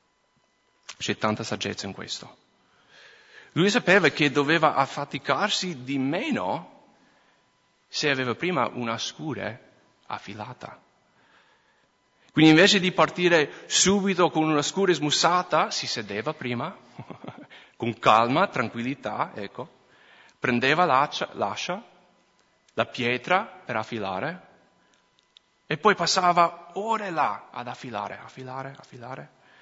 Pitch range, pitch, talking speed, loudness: 125-180 Hz, 150 Hz, 105 wpm, -24 LUFS